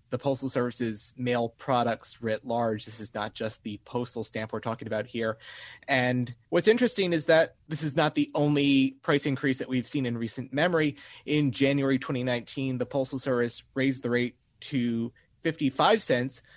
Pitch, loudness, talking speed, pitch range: 125 Hz, -28 LUFS, 175 wpm, 115-140 Hz